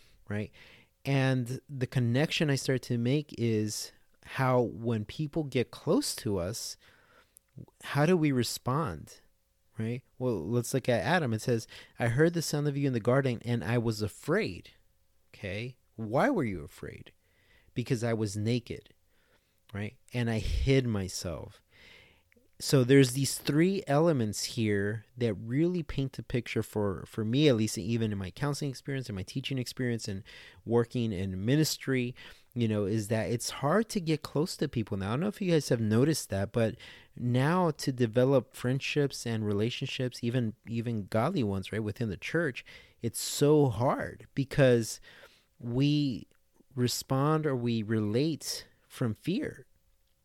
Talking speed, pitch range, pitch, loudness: 155 wpm, 110-135 Hz, 120 Hz, -30 LUFS